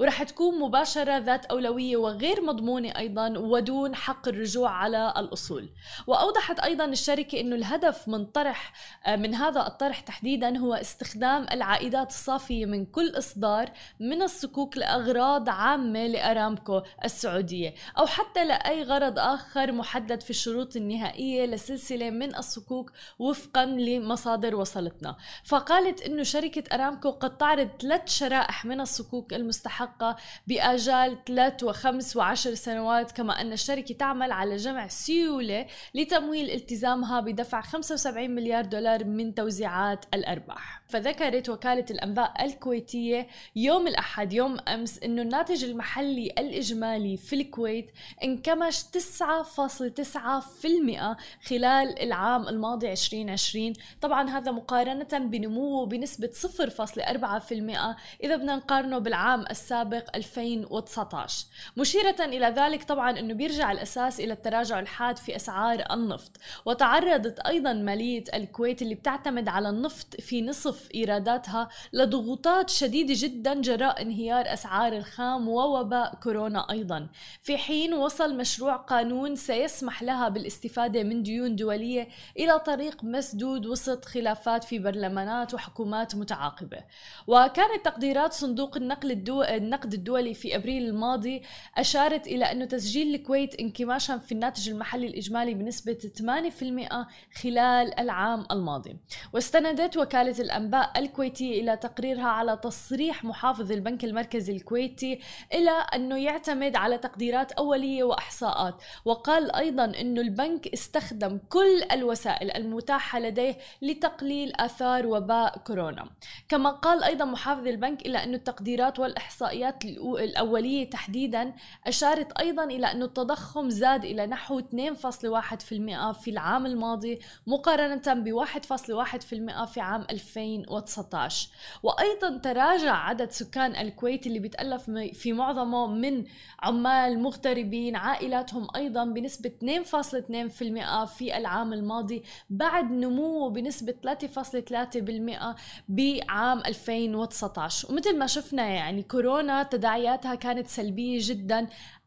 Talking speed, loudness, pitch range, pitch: 115 wpm, -28 LUFS, 225-275 Hz, 245 Hz